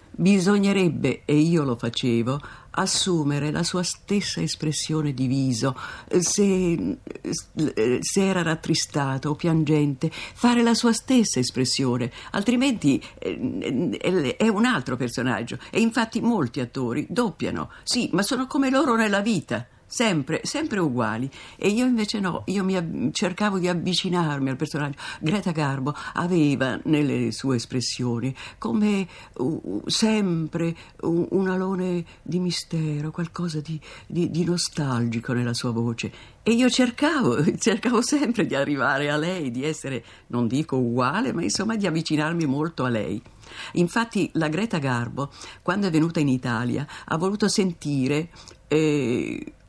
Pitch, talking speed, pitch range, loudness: 160 Hz, 135 wpm, 130-195 Hz, -24 LUFS